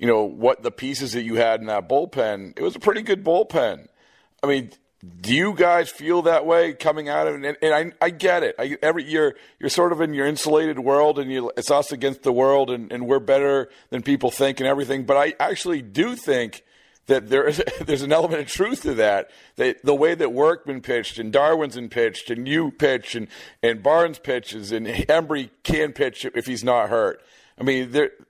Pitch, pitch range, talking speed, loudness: 140 Hz, 125-165 Hz, 215 wpm, -21 LUFS